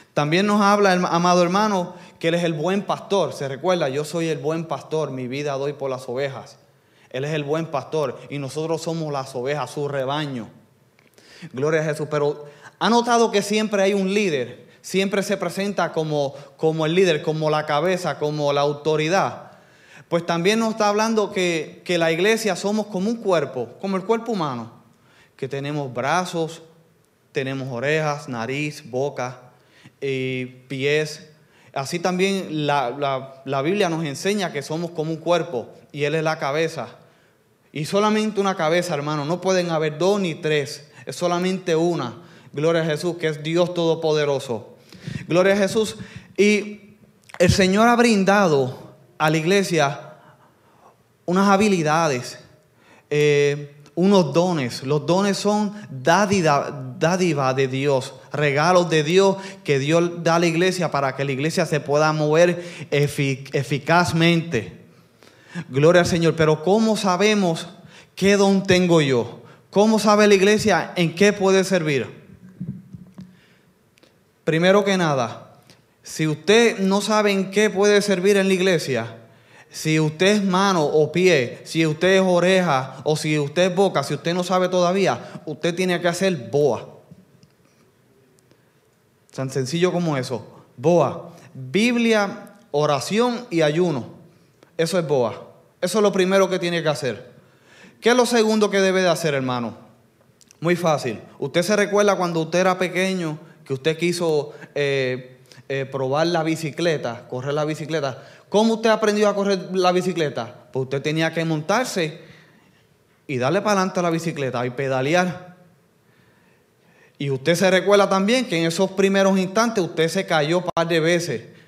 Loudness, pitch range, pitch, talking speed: -21 LUFS, 145-190 Hz, 165 Hz, 155 wpm